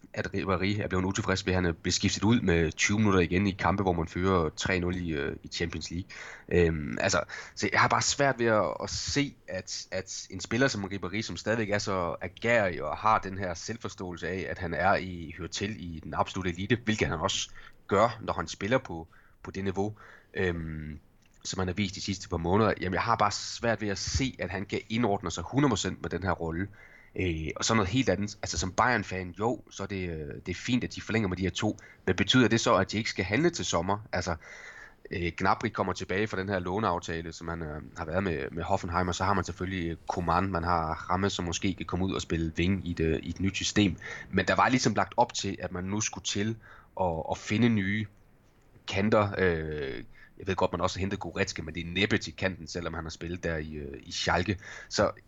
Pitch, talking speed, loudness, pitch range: 95 Hz, 235 wpm, -29 LUFS, 85-105 Hz